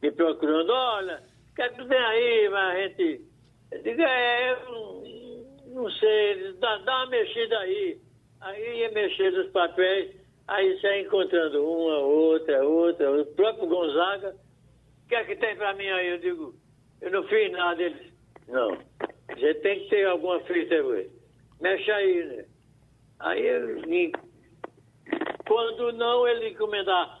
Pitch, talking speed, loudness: 235 Hz, 155 wpm, -26 LUFS